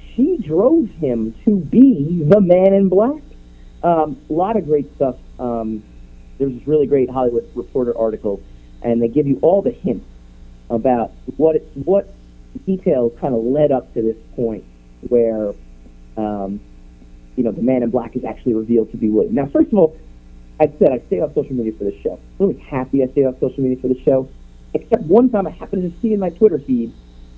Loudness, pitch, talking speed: -17 LUFS, 125 Hz, 200 wpm